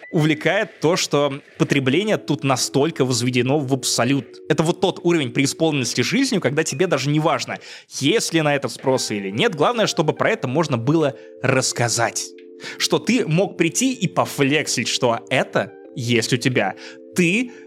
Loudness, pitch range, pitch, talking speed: -20 LUFS, 130-165 Hz, 145 Hz, 155 wpm